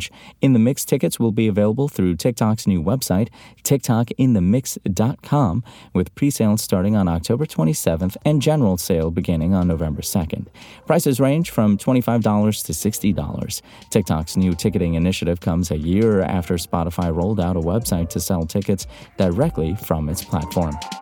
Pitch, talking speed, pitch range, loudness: 100 Hz, 145 wpm, 85-115 Hz, -20 LUFS